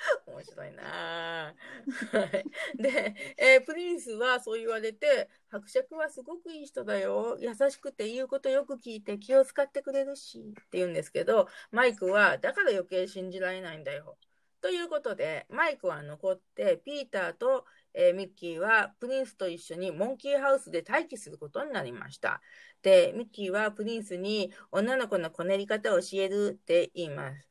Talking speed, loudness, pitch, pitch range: 355 characters per minute, -30 LUFS, 245 Hz, 195-285 Hz